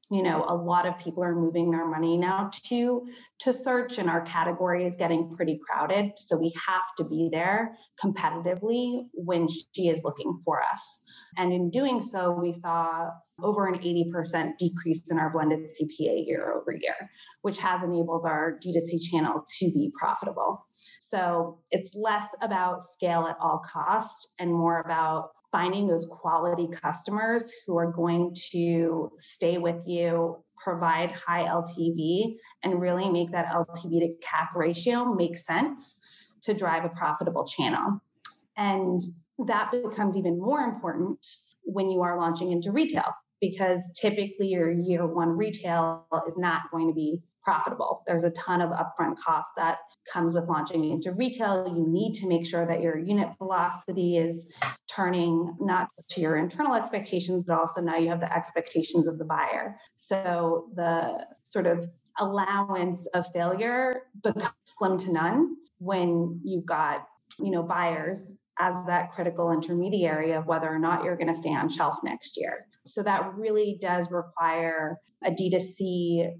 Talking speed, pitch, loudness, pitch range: 160 wpm, 175 Hz, -28 LUFS, 165-195 Hz